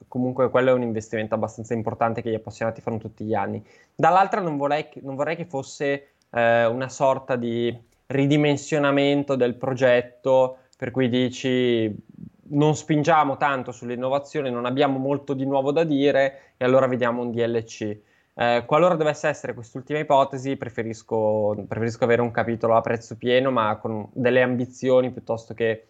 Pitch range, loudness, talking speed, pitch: 115-140 Hz, -23 LUFS, 160 wpm, 125 Hz